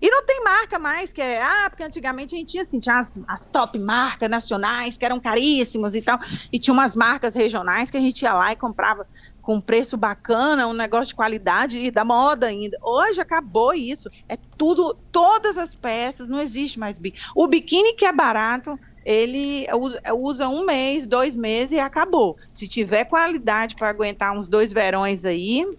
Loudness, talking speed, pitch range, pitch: -21 LUFS, 190 wpm, 220-300 Hz, 245 Hz